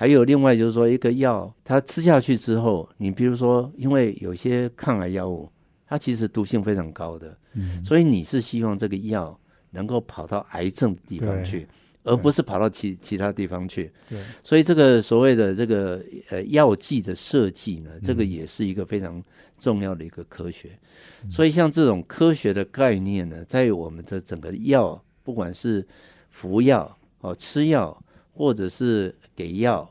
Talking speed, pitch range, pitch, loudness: 265 characters per minute, 90-125 Hz, 105 Hz, -22 LUFS